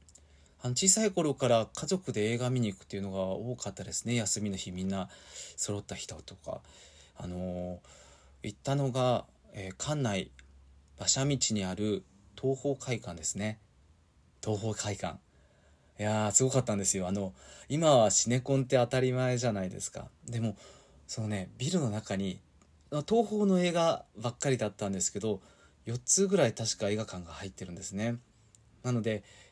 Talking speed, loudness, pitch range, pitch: 320 characters per minute, -31 LUFS, 95-125 Hz, 105 Hz